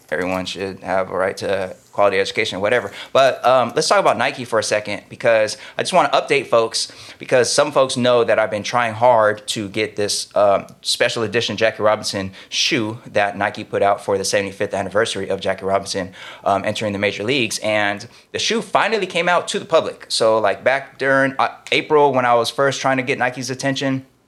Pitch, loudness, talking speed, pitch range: 115 Hz, -18 LUFS, 205 wpm, 105-135 Hz